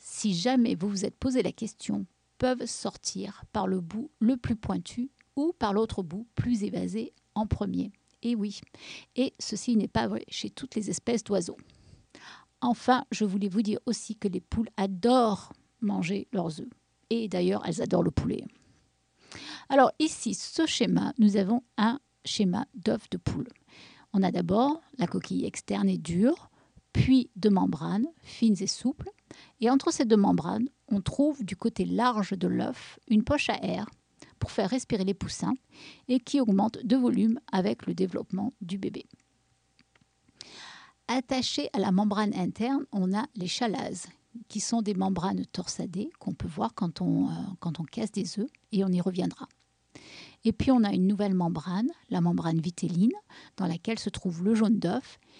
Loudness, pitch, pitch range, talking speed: -29 LUFS, 220 Hz, 195-245 Hz, 170 wpm